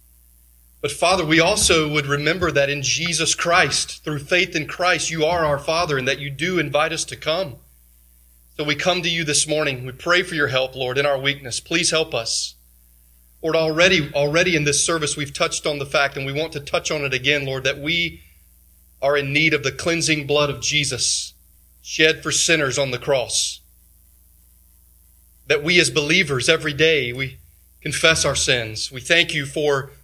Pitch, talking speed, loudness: 145 Hz, 190 wpm, -19 LUFS